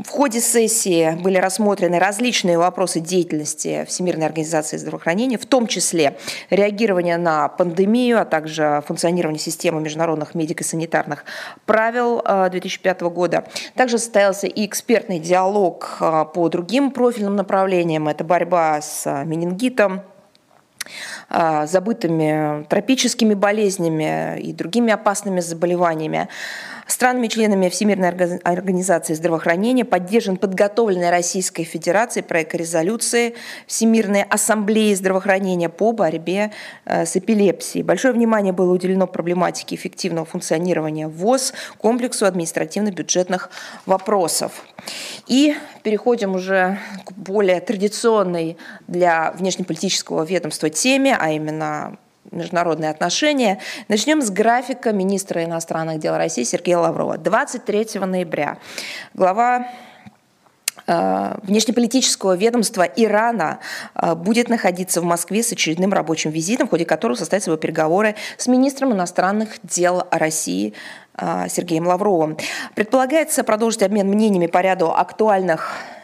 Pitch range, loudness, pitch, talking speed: 170-220 Hz, -19 LUFS, 185 Hz, 105 wpm